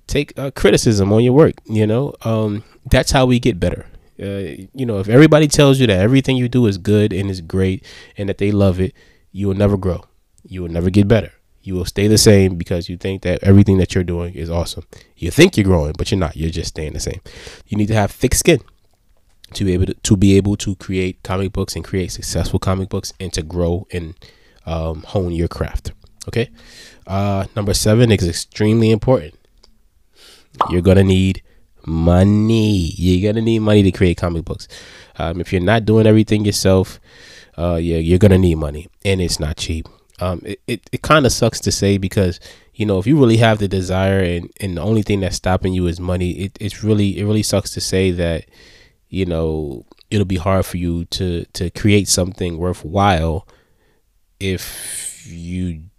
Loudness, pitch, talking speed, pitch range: -17 LUFS, 95 Hz, 205 wpm, 90-105 Hz